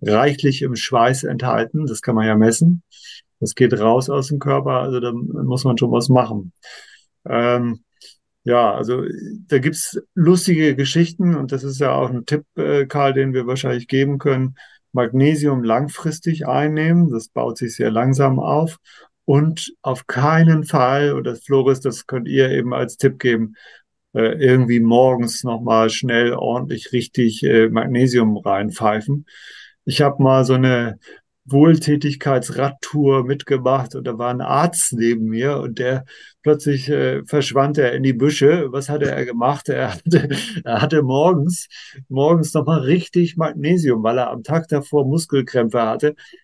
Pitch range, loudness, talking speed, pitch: 125-150 Hz, -18 LUFS, 155 wpm, 135 Hz